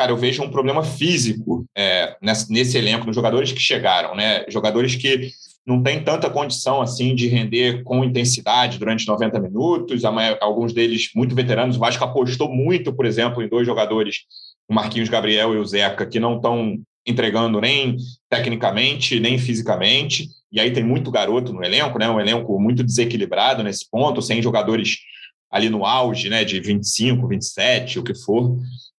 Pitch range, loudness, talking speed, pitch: 115-130 Hz, -19 LUFS, 170 wpm, 120 Hz